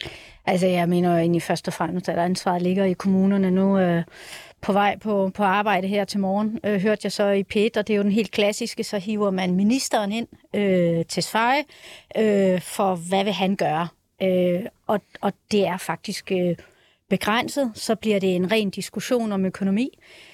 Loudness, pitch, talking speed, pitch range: -23 LUFS, 195 Hz, 170 wpm, 185-210 Hz